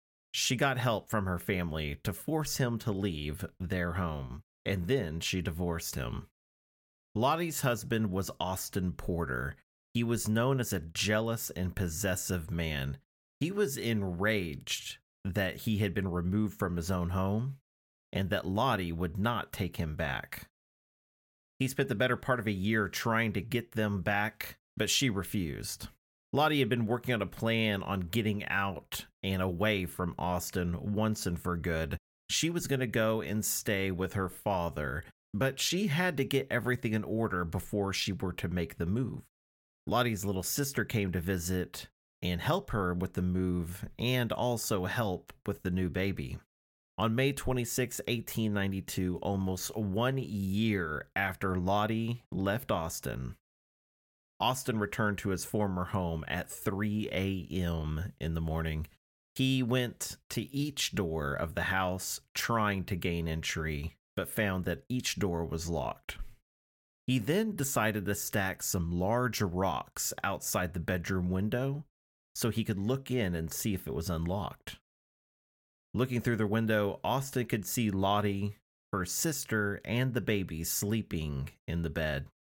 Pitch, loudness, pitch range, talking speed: 100 Hz, -33 LUFS, 85-115 Hz, 155 wpm